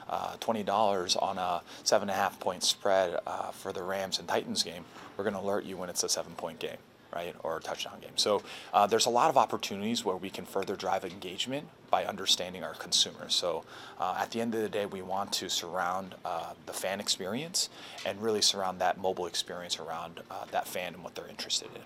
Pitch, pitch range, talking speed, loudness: 100 Hz, 95-115 Hz, 220 wpm, -31 LUFS